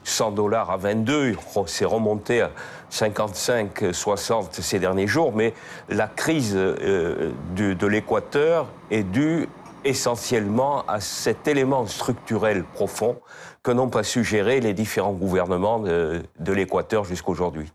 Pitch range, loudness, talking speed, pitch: 95-130 Hz, -23 LUFS, 125 wpm, 110 Hz